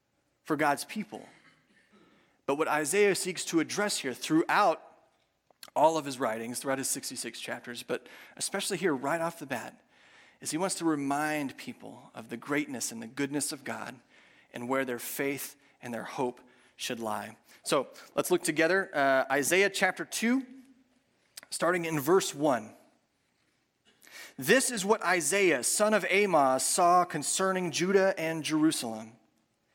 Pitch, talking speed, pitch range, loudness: 160 Hz, 145 wpm, 140-190 Hz, -29 LUFS